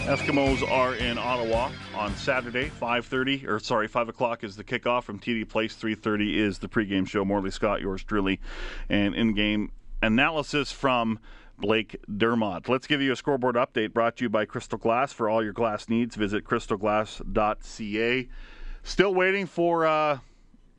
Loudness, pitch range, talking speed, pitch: -26 LUFS, 105-130 Hz, 160 wpm, 115 Hz